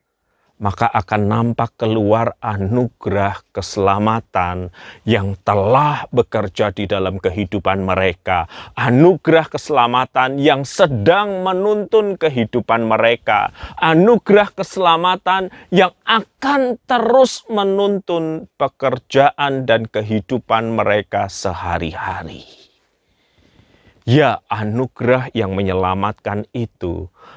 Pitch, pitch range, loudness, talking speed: 115 Hz, 105-165 Hz, -17 LUFS, 80 wpm